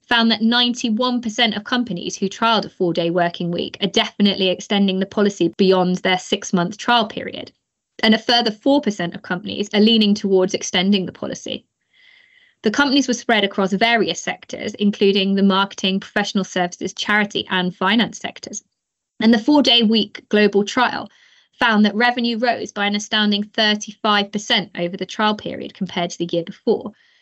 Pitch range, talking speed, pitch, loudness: 190-235 Hz, 165 wpm, 210 Hz, -18 LUFS